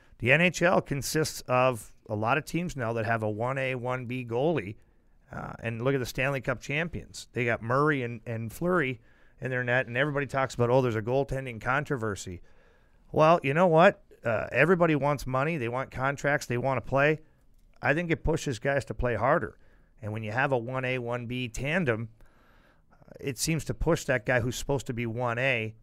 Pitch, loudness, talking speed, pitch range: 130 Hz, -28 LUFS, 195 wpm, 115-145 Hz